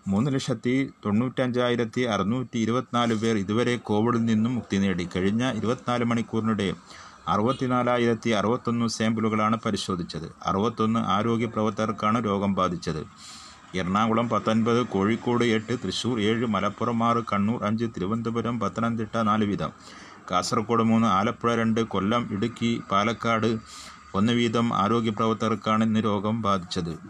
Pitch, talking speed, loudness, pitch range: 115 Hz, 115 wpm, -25 LUFS, 105-120 Hz